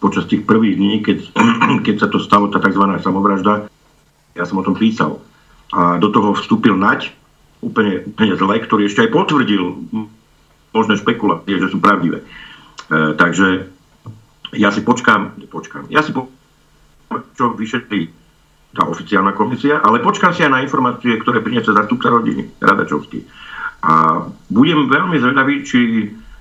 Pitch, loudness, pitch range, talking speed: 100 Hz, -15 LUFS, 95-110 Hz, 145 wpm